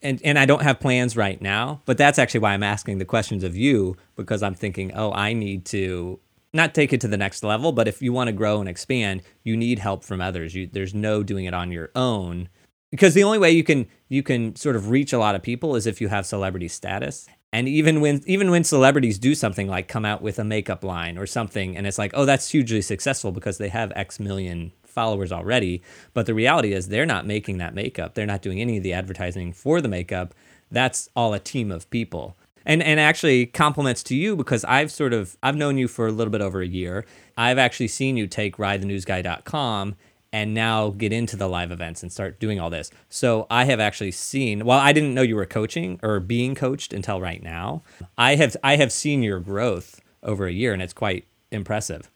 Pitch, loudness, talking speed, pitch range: 110 Hz, -22 LUFS, 230 wpm, 95-125 Hz